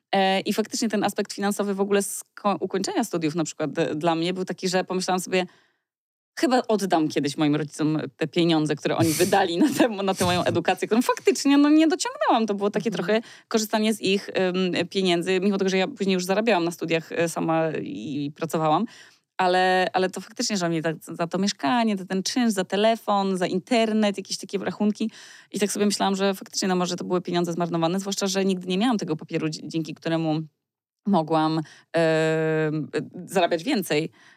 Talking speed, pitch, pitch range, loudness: 180 wpm, 185 Hz, 165-205 Hz, -24 LUFS